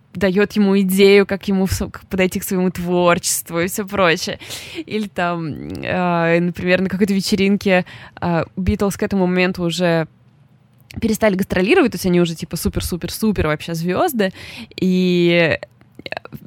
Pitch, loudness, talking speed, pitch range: 185 Hz, -18 LUFS, 140 wpm, 175-200 Hz